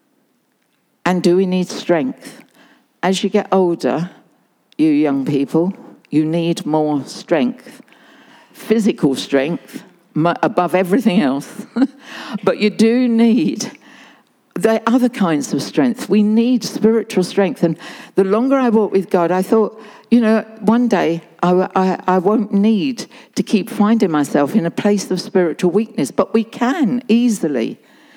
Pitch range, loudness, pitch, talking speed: 180-245 Hz, -16 LUFS, 210 Hz, 140 wpm